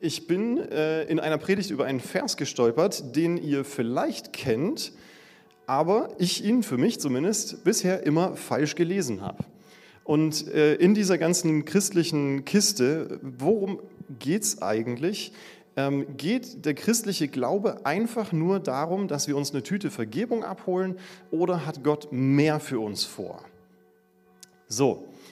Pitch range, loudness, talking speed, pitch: 140-195 Hz, -26 LUFS, 135 wpm, 160 Hz